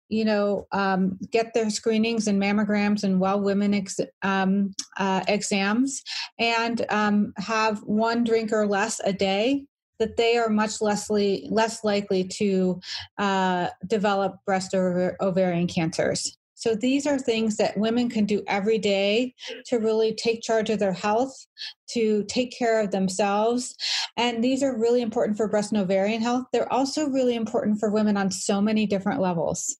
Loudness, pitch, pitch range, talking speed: -24 LUFS, 215 Hz, 200-230 Hz, 165 wpm